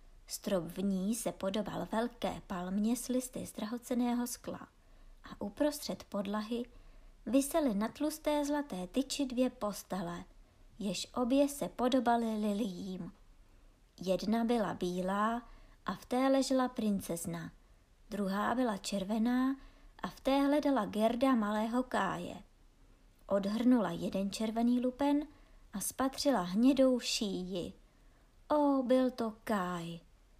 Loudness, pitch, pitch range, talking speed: -34 LUFS, 225 Hz, 195-255 Hz, 110 wpm